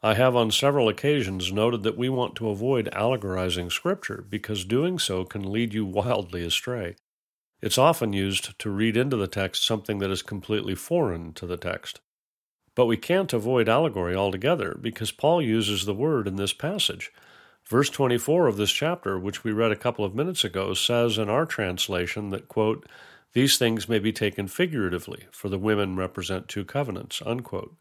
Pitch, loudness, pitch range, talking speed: 110 Hz, -25 LUFS, 95-125 Hz, 180 wpm